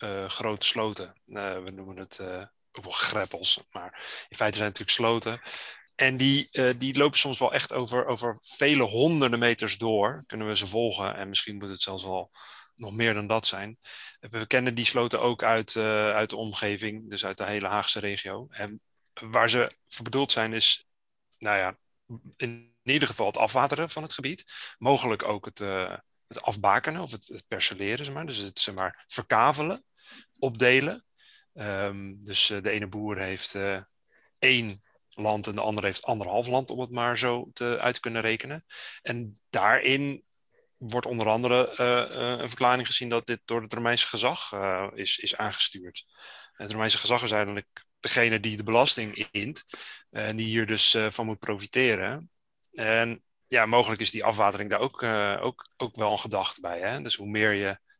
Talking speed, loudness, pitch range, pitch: 190 wpm, -26 LUFS, 105-125 Hz, 110 Hz